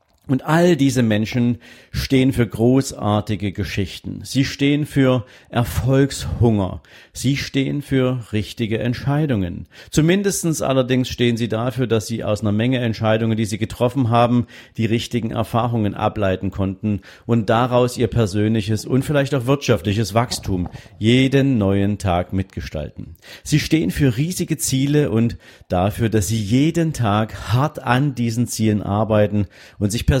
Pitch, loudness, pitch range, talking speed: 115 Hz, -19 LUFS, 105-130 Hz, 135 wpm